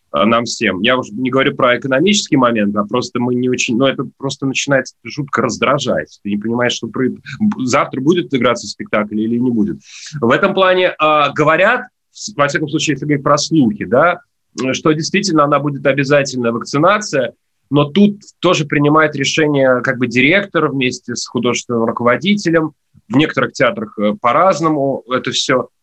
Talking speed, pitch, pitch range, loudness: 165 wpm, 135 Hz, 120-155 Hz, -15 LUFS